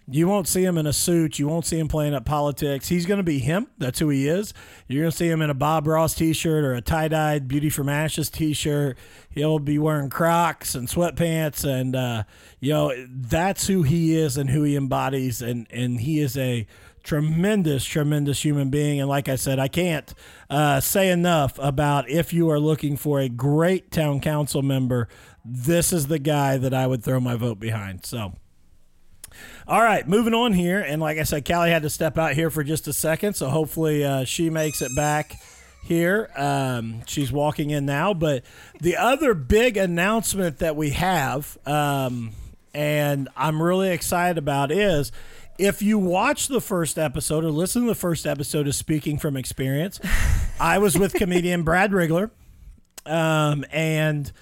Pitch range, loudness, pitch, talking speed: 140-170 Hz, -22 LUFS, 150 Hz, 190 wpm